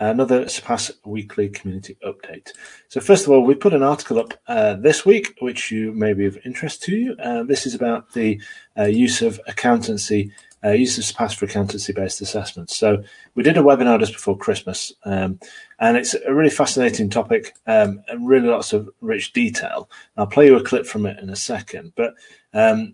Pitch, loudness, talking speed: 125 Hz, -19 LUFS, 205 wpm